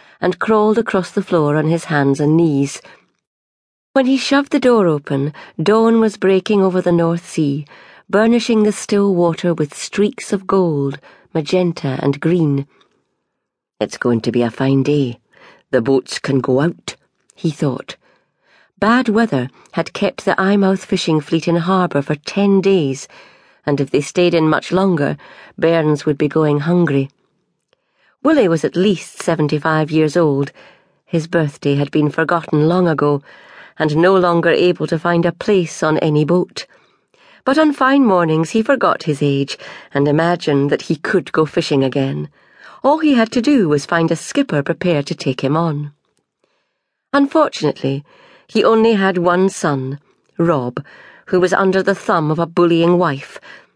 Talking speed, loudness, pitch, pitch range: 160 wpm, -16 LUFS, 170 Hz, 145-195 Hz